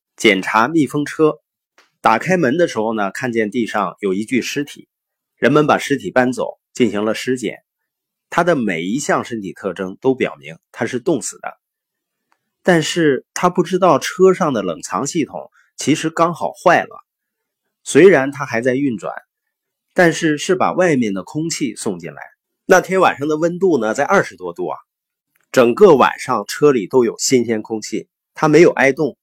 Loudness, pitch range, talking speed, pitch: -16 LUFS, 125-180 Hz, 245 characters per minute, 150 Hz